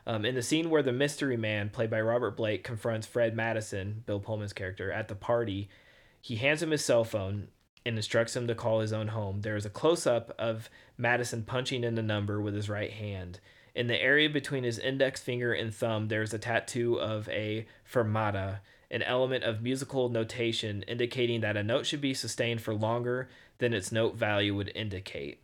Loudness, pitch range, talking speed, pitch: -31 LUFS, 105-120 Hz, 200 wpm, 115 Hz